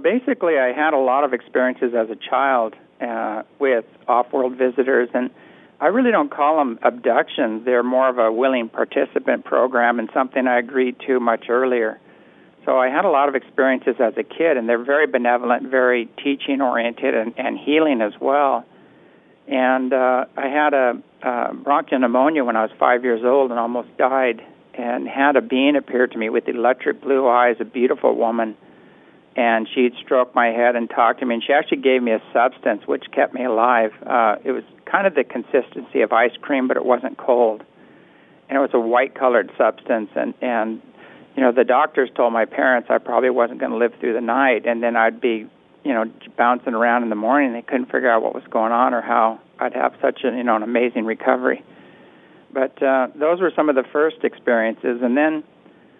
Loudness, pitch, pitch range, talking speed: -19 LUFS, 125 Hz, 115-130 Hz, 205 wpm